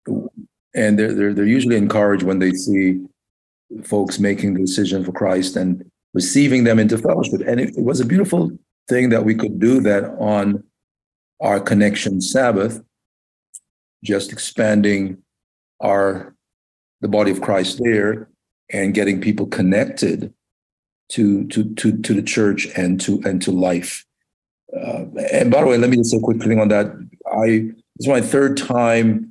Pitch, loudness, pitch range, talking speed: 105 Hz, -18 LUFS, 95-115 Hz, 160 wpm